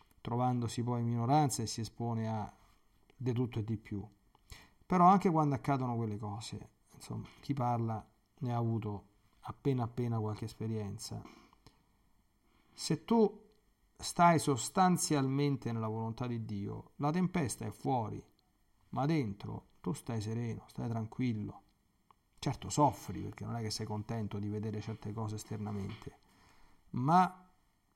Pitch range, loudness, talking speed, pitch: 105-140 Hz, -35 LUFS, 135 wpm, 115 Hz